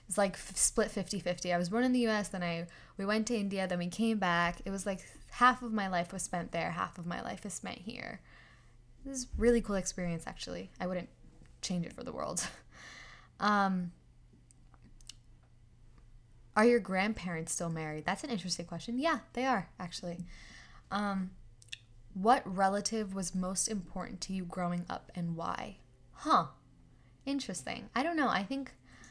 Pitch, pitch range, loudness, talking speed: 190 Hz, 170-220 Hz, -34 LUFS, 175 wpm